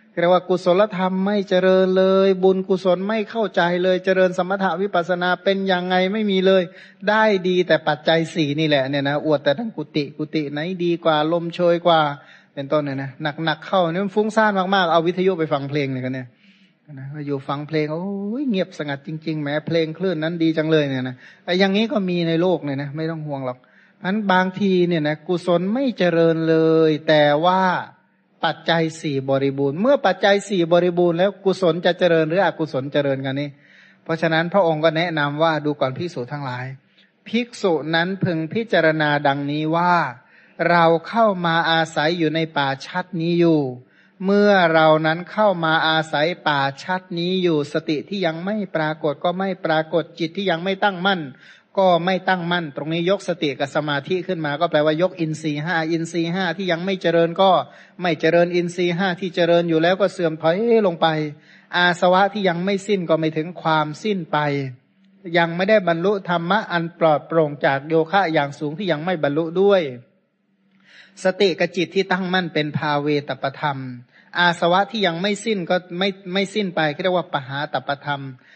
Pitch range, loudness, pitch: 155-190 Hz, -20 LUFS, 170 Hz